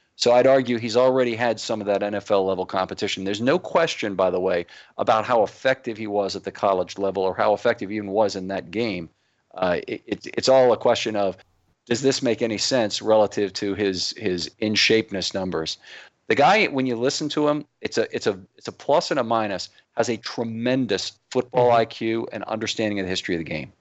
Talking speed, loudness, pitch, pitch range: 210 wpm, -22 LUFS, 110 Hz, 95-120 Hz